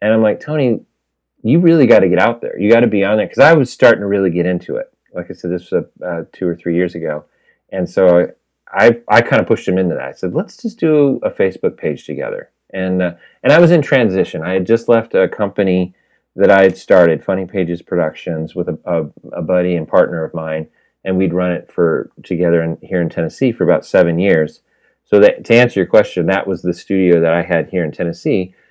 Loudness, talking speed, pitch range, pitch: -14 LUFS, 245 wpm, 85-105 Hz, 90 Hz